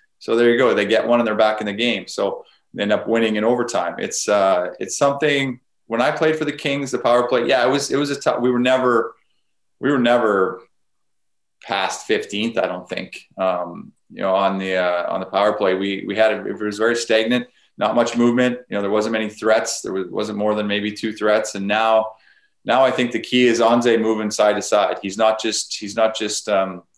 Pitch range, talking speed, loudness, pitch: 105-120 Hz, 235 wpm, -19 LUFS, 110 Hz